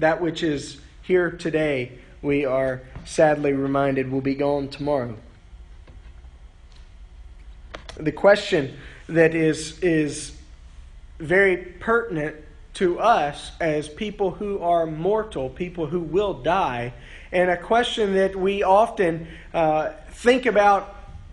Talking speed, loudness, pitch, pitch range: 115 wpm, -22 LUFS, 155 Hz, 130-180 Hz